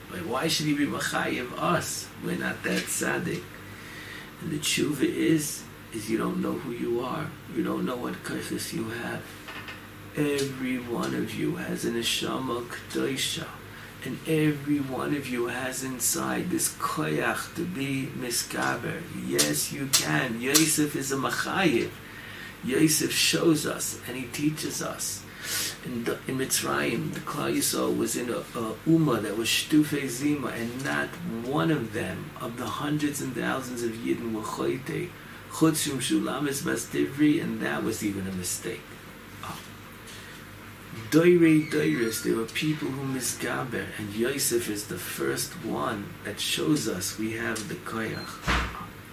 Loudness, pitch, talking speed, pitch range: -28 LUFS, 125 Hz, 155 wpm, 110-150 Hz